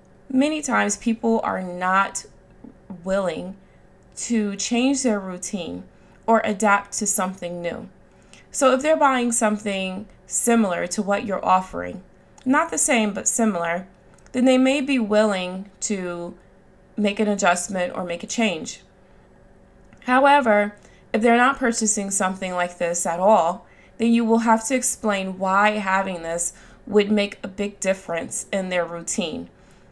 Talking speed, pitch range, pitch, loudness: 140 wpm, 185-230 Hz, 205 Hz, -21 LUFS